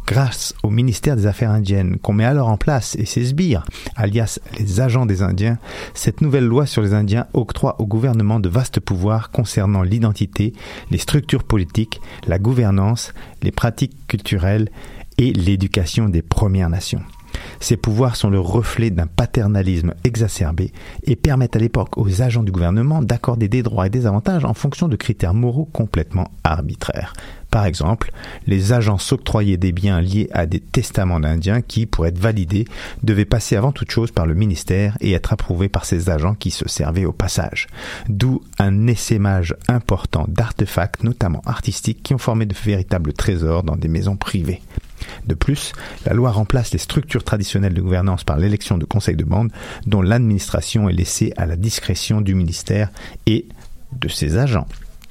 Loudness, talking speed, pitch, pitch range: -19 LUFS, 170 wpm, 105 Hz, 95-115 Hz